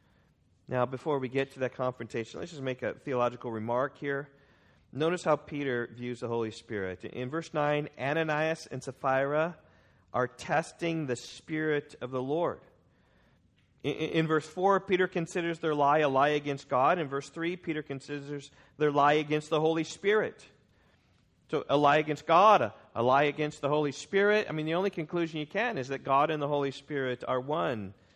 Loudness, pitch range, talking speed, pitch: -30 LUFS, 130-155 Hz, 180 wpm, 145 Hz